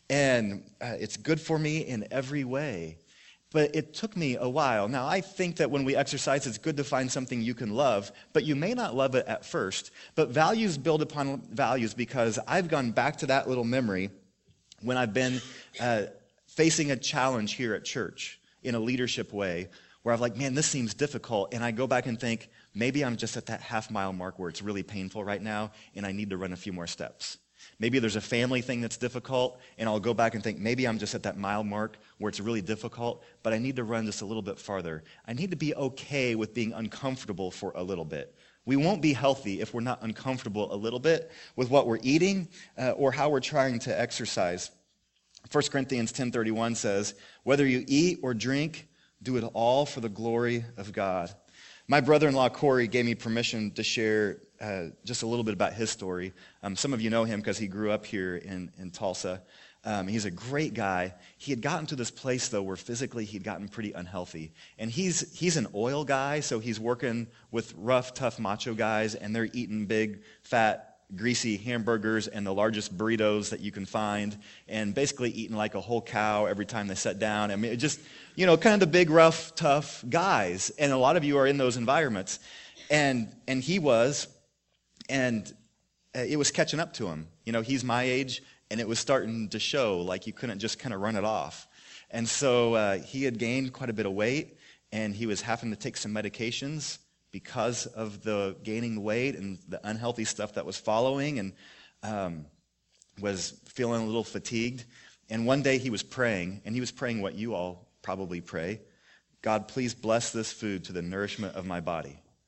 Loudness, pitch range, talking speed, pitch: -30 LUFS, 105-135 Hz, 210 wpm, 115 Hz